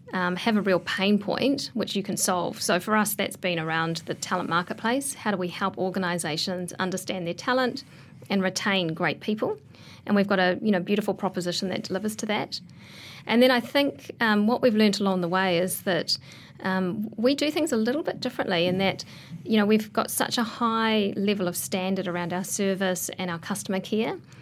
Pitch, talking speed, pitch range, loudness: 195 Hz, 205 wpm, 180-220 Hz, -26 LUFS